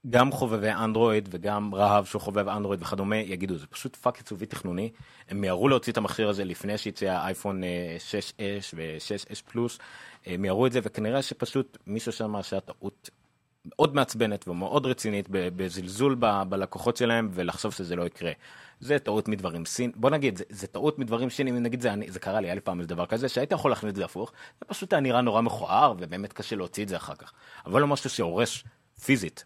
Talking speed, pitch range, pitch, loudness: 185 wpm, 95-120 Hz, 105 Hz, -28 LUFS